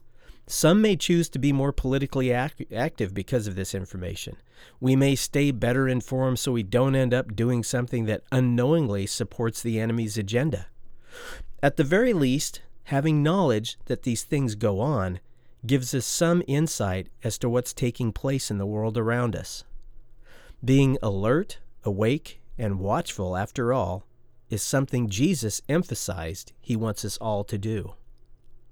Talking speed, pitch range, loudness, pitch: 150 wpm, 110-135 Hz, -25 LUFS, 120 Hz